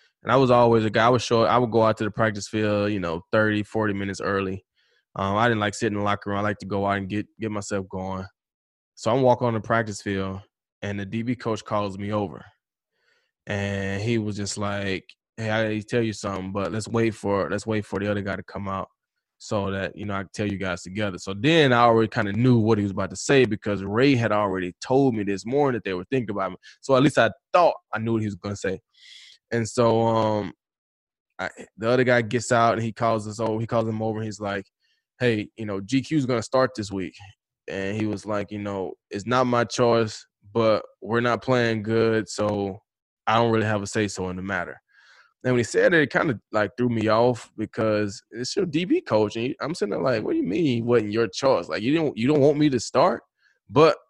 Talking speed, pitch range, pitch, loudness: 250 wpm, 100-115 Hz, 110 Hz, -24 LUFS